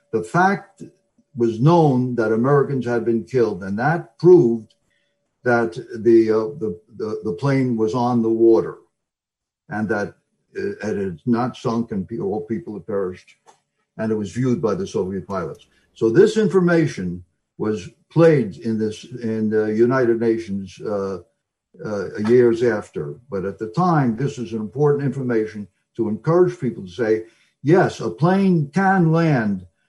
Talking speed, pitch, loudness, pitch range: 155 wpm, 120 Hz, -20 LUFS, 110-155 Hz